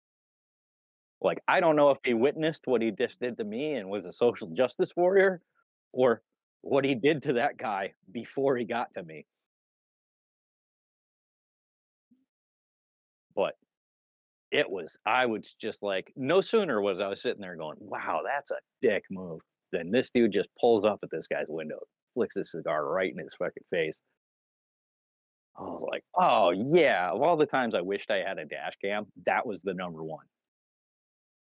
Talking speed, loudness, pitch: 170 wpm, -29 LUFS, 150 Hz